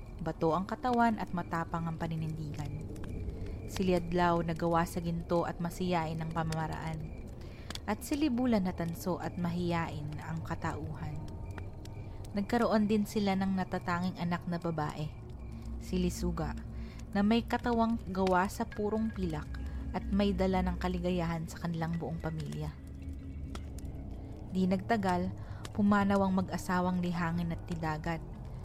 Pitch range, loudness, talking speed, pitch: 125-185 Hz, -34 LUFS, 120 wpm, 170 Hz